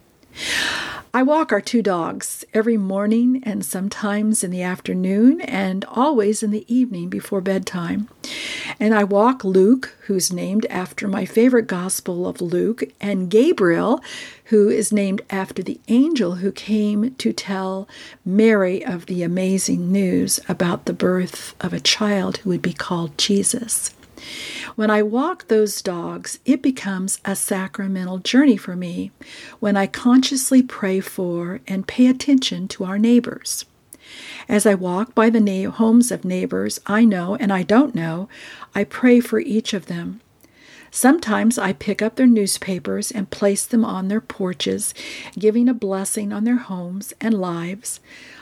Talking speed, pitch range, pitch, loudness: 150 wpm, 190-230 Hz, 205 Hz, -20 LUFS